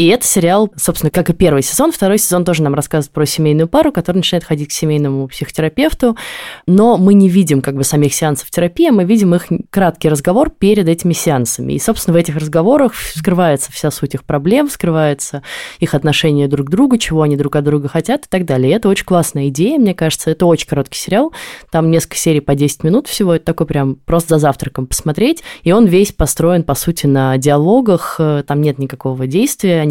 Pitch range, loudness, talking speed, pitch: 150-195 Hz, -13 LUFS, 205 wpm, 165 Hz